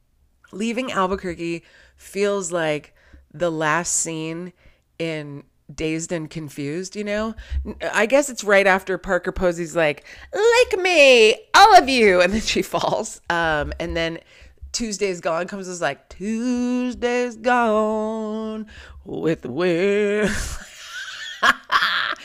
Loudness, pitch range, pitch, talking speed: -20 LUFS, 165-220 Hz, 185 Hz, 115 wpm